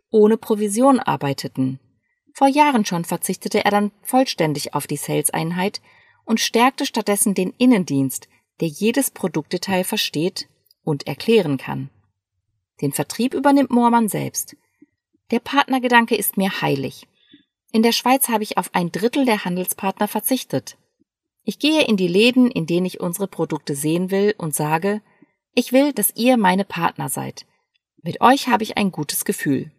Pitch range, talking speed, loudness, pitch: 165-240 Hz, 150 wpm, -19 LUFS, 205 Hz